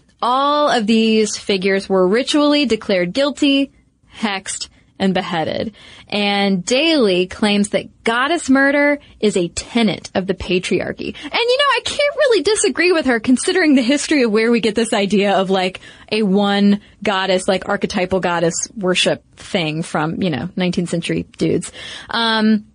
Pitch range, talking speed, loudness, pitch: 190-270 Hz, 155 wpm, -17 LUFS, 215 Hz